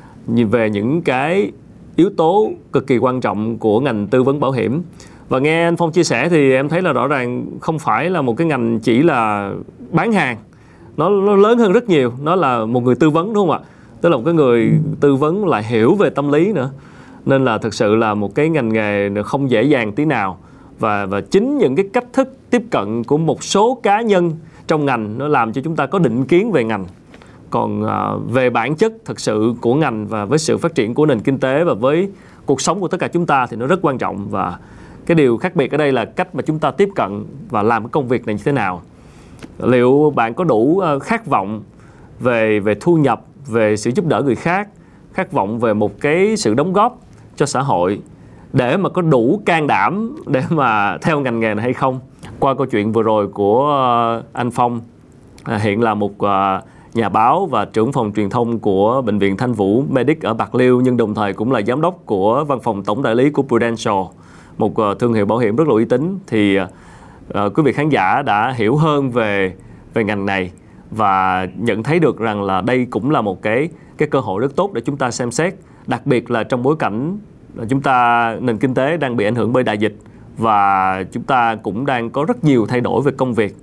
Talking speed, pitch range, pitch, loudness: 225 wpm, 110-150 Hz, 125 Hz, -16 LUFS